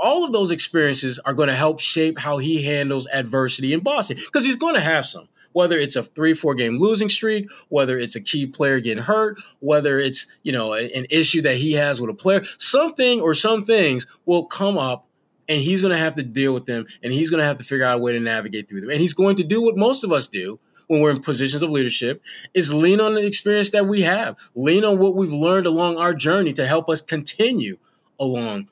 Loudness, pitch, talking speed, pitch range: -20 LUFS, 160 Hz, 240 wpm, 135-195 Hz